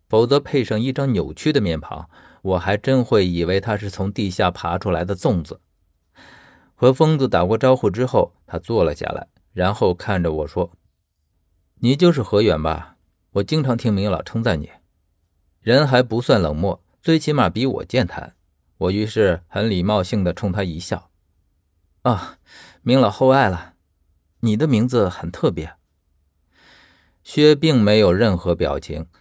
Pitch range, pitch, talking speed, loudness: 85-120 Hz, 95 Hz, 225 characters per minute, -19 LUFS